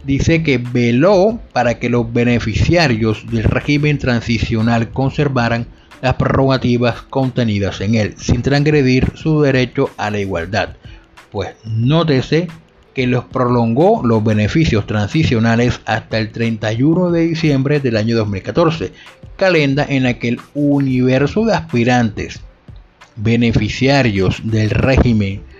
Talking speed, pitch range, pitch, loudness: 115 wpm, 110-140 Hz, 120 Hz, -15 LUFS